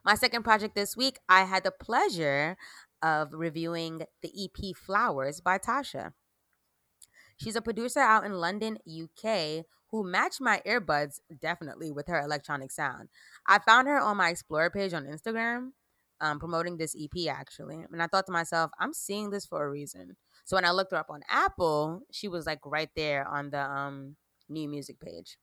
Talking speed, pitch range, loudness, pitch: 180 wpm, 150-210 Hz, -29 LUFS, 170 Hz